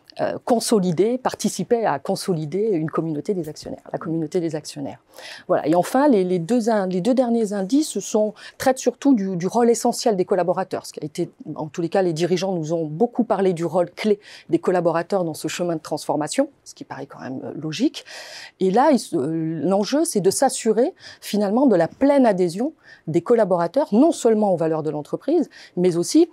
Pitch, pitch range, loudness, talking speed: 195 Hz, 170-240 Hz, -21 LUFS, 190 wpm